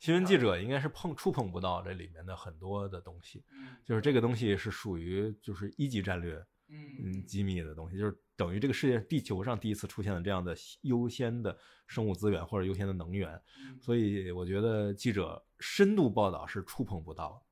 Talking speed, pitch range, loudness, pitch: 315 characters per minute, 95-125 Hz, -34 LUFS, 105 Hz